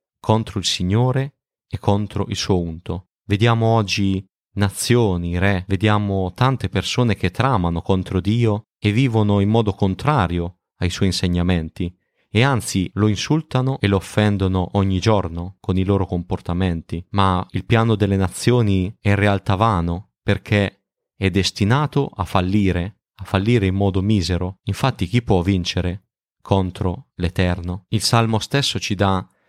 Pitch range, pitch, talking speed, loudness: 90-110 Hz, 100 Hz, 140 wpm, -20 LUFS